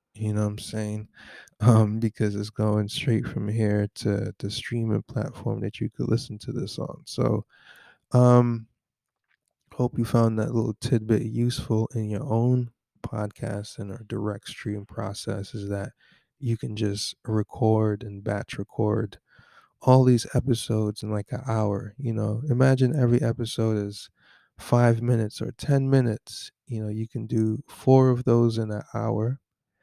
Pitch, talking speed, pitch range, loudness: 115 Hz, 160 wpm, 105-120 Hz, -26 LUFS